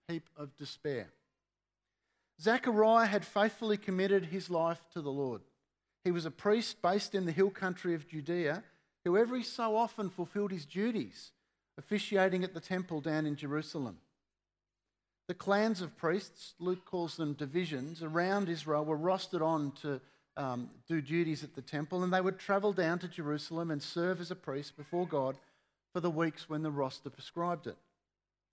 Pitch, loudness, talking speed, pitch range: 170 Hz, -35 LUFS, 165 wpm, 150-190 Hz